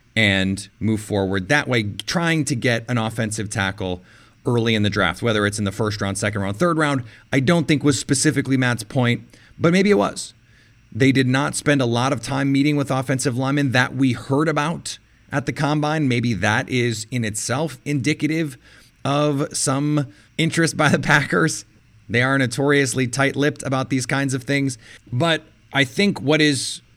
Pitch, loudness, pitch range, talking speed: 130 Hz, -20 LUFS, 115-145 Hz, 180 wpm